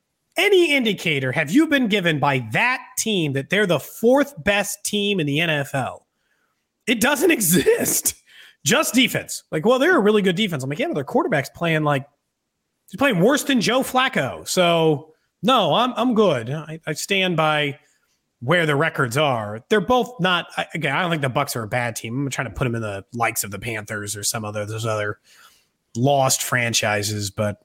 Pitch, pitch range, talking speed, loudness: 155 Hz, 125-215 Hz, 195 wpm, -20 LUFS